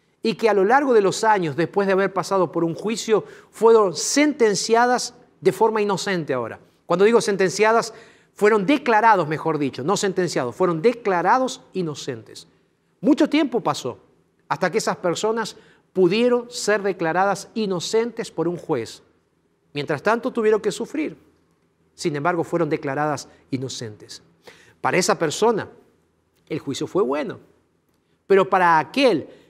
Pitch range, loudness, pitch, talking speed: 170-225 Hz, -21 LUFS, 200 Hz, 135 wpm